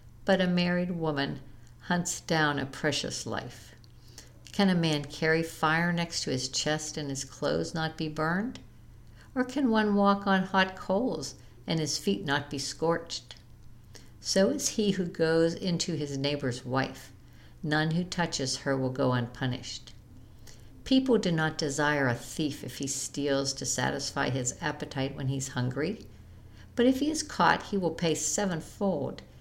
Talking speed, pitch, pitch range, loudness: 160 wpm, 150 Hz, 125-175 Hz, -29 LUFS